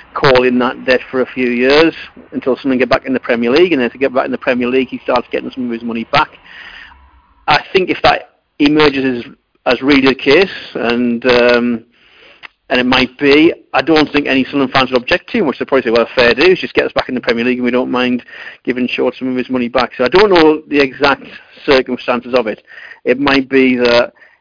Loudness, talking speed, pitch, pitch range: -13 LUFS, 245 wpm, 130 Hz, 125-140 Hz